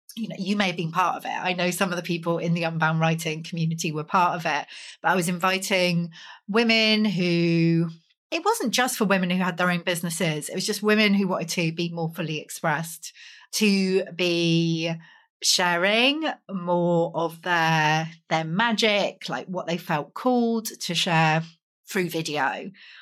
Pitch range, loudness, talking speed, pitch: 165-200 Hz, -24 LUFS, 175 wpm, 175 Hz